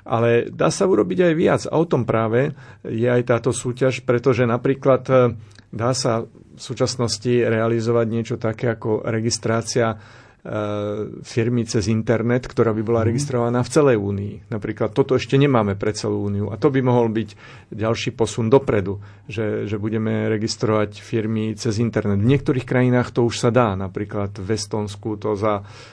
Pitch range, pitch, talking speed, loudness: 110-125 Hz, 115 Hz, 160 wpm, -20 LUFS